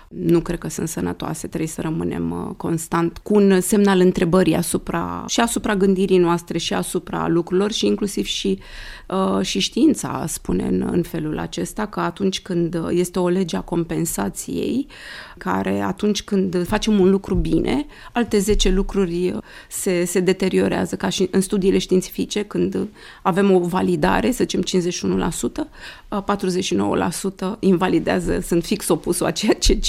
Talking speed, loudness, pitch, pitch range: 145 wpm, -20 LUFS, 185 Hz, 175-195 Hz